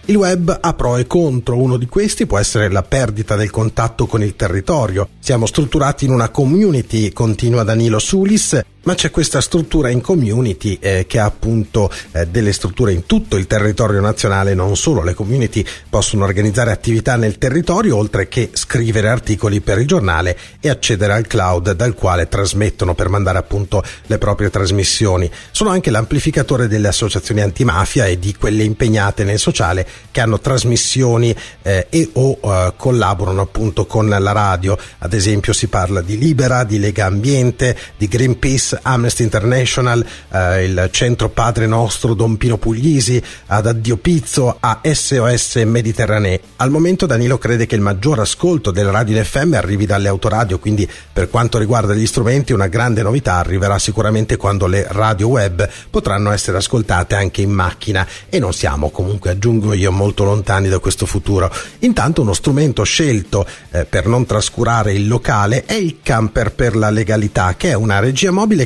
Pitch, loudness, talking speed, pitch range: 110 Hz, -15 LUFS, 165 wpm, 100-125 Hz